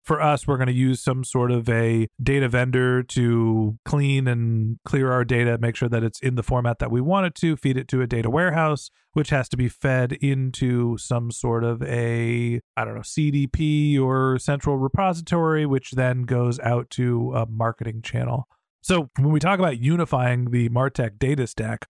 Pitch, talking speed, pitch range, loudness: 125 Hz, 195 wpm, 120-140 Hz, -22 LUFS